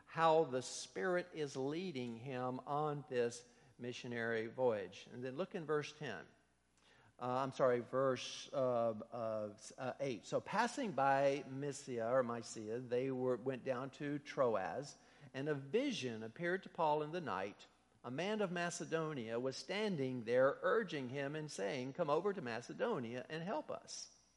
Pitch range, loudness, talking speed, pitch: 120-155 Hz, -40 LUFS, 155 wpm, 135 Hz